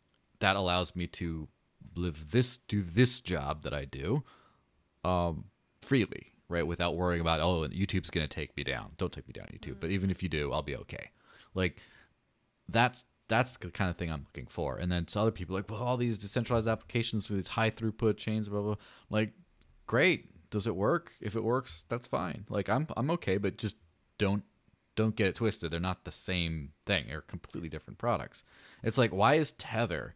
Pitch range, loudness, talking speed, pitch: 85-110 Hz, -33 LUFS, 200 wpm, 95 Hz